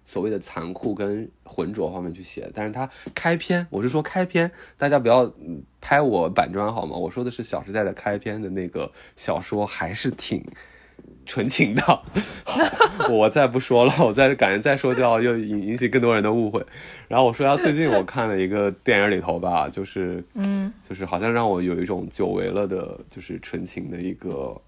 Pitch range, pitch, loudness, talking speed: 95-135 Hz, 115 Hz, -22 LUFS, 280 characters per minute